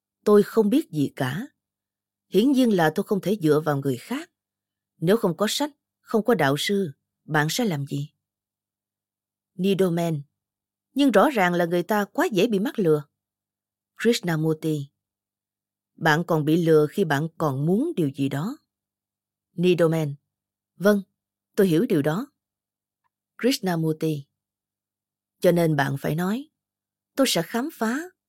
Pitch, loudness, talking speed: 160 Hz, -23 LUFS, 140 wpm